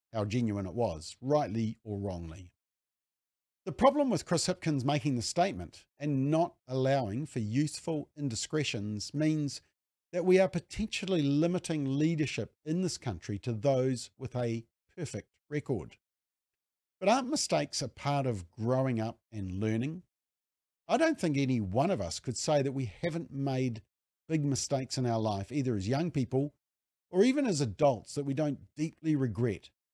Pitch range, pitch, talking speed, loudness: 115-155 Hz, 135 Hz, 155 wpm, -32 LUFS